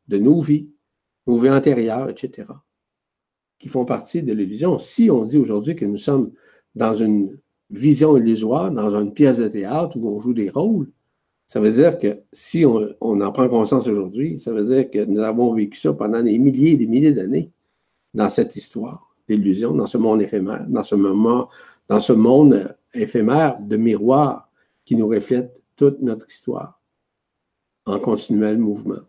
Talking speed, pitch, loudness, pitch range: 175 wpm, 115 Hz, -18 LUFS, 105-140 Hz